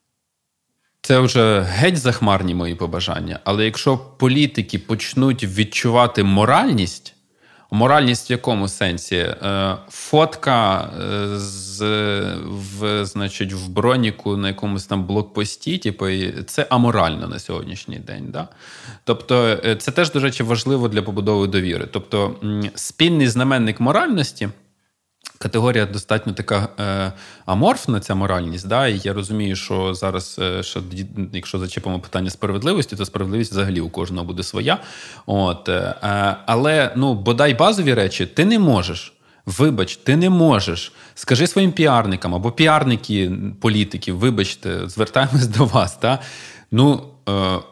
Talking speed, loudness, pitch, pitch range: 120 wpm, -19 LUFS, 105 Hz, 95-125 Hz